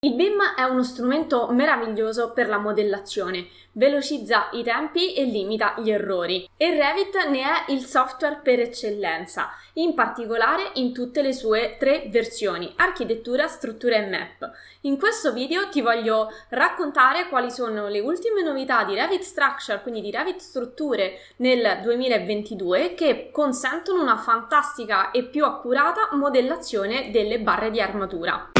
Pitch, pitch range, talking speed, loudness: 255 Hz, 220-290 Hz, 145 wpm, -23 LUFS